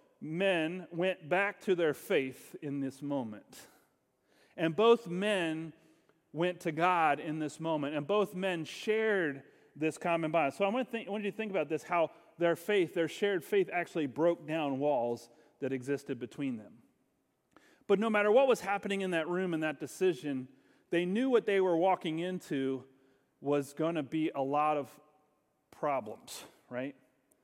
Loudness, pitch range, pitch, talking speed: -33 LUFS, 150-190 Hz, 165 Hz, 165 wpm